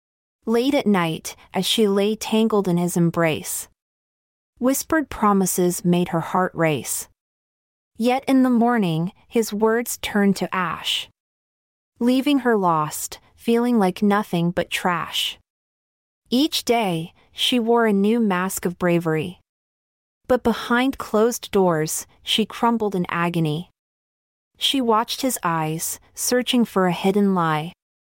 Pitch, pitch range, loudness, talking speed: 205 Hz, 175-235 Hz, -21 LUFS, 125 wpm